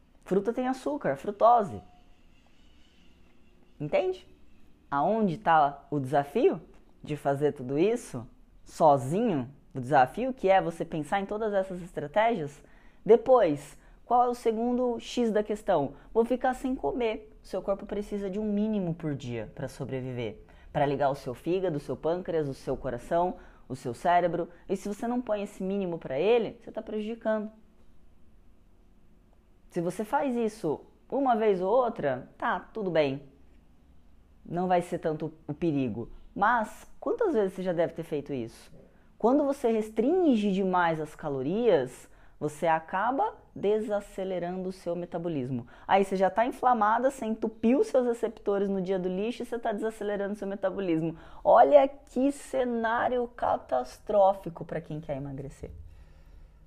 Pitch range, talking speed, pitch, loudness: 140-220 Hz, 145 wpm, 185 Hz, -28 LUFS